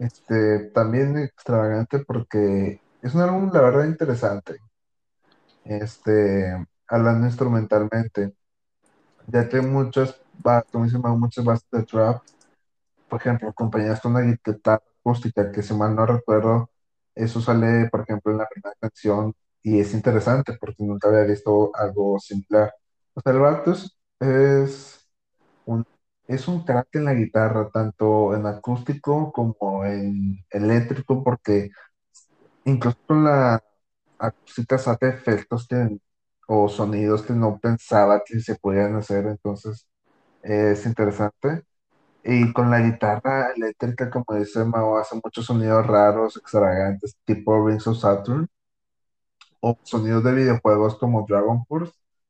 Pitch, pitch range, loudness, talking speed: 110 Hz, 105-125 Hz, -22 LUFS, 130 wpm